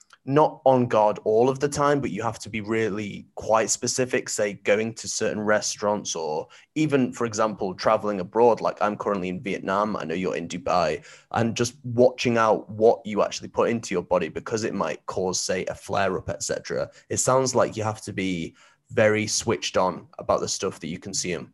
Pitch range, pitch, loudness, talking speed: 105-125 Hz, 115 Hz, -24 LUFS, 200 wpm